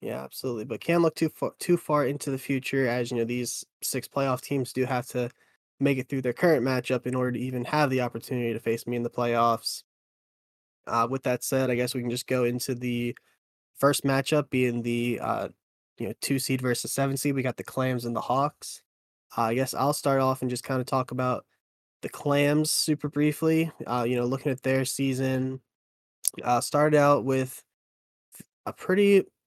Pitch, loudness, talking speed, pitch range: 130 Hz, -27 LUFS, 205 wpm, 120-140 Hz